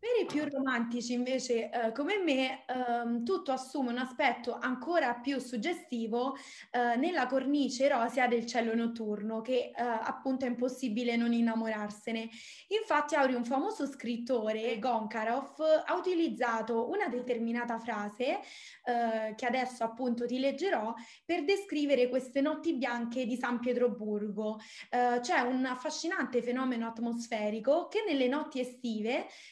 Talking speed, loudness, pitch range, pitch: 135 wpm, -33 LUFS, 235-275 Hz, 250 Hz